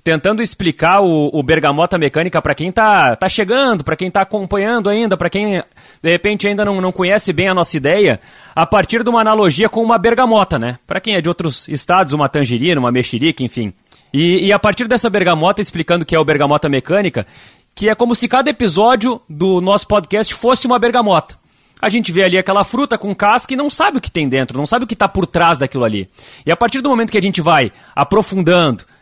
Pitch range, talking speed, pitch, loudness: 160-215 Hz, 220 wpm, 190 Hz, -14 LUFS